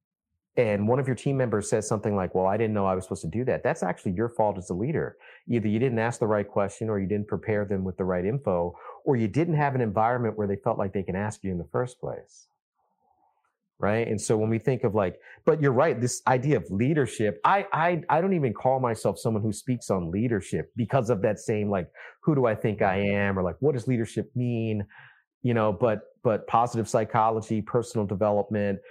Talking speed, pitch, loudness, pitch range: 230 wpm, 110 Hz, -26 LUFS, 100-125 Hz